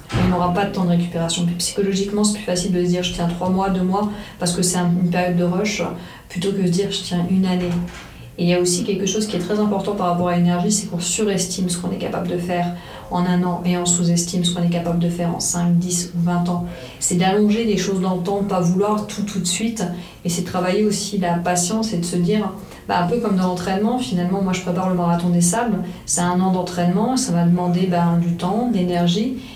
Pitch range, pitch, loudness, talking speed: 175-195 Hz, 180 Hz, -20 LUFS, 260 wpm